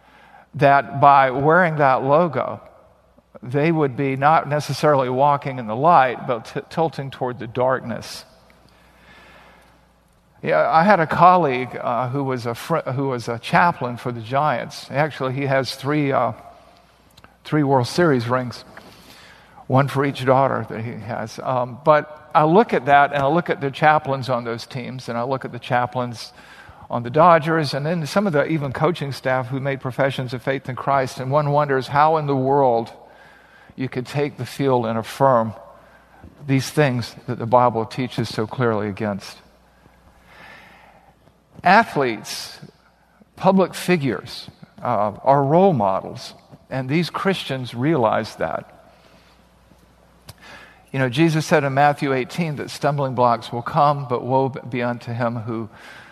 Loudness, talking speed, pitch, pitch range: -20 LUFS, 155 wpm, 135 Hz, 125-150 Hz